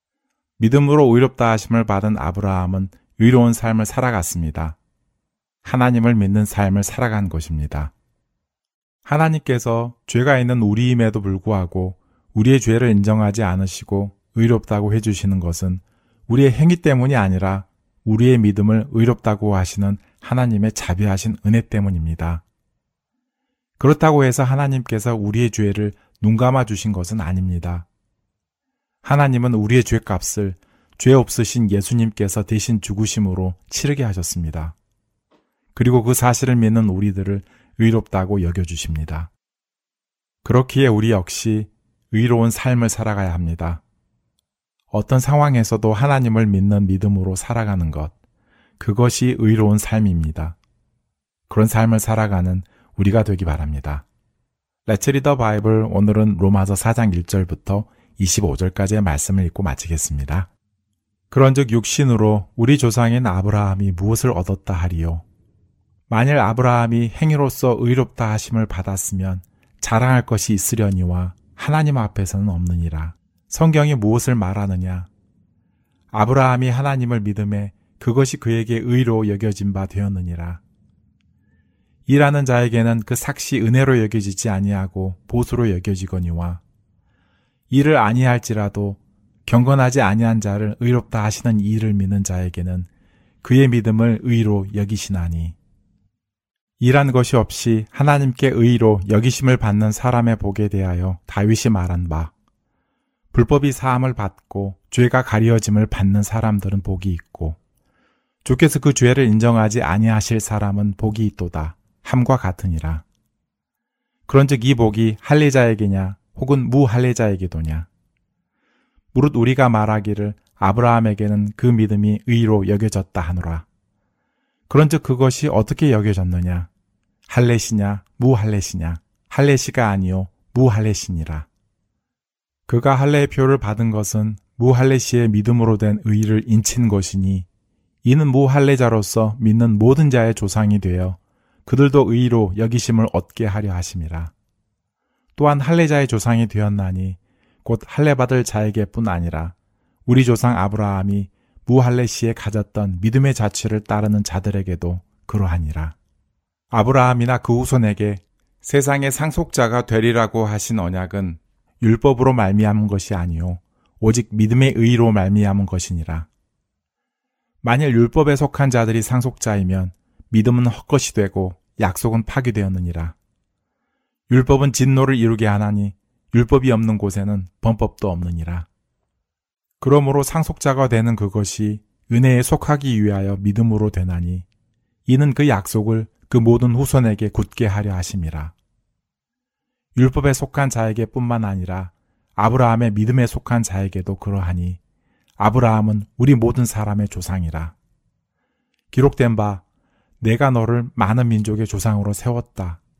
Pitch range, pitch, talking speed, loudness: 95-120 Hz, 110 Hz, 300 characters per minute, -18 LUFS